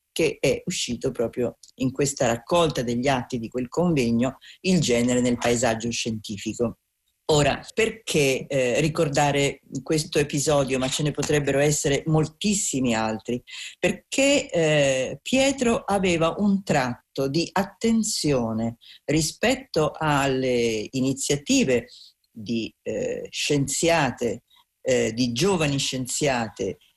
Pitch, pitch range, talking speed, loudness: 140 Hz, 125-170 Hz, 105 wpm, -24 LUFS